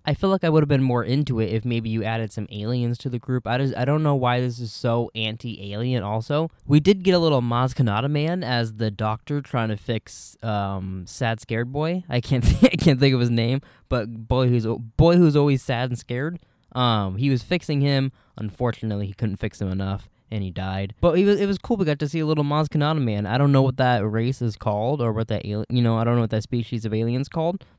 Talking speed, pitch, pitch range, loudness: 255 wpm, 120 Hz, 110-145 Hz, -23 LUFS